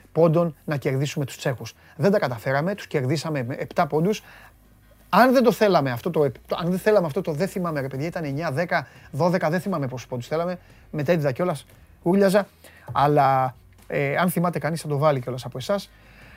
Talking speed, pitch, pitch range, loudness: 170 wpm, 155 Hz, 135-180 Hz, -23 LUFS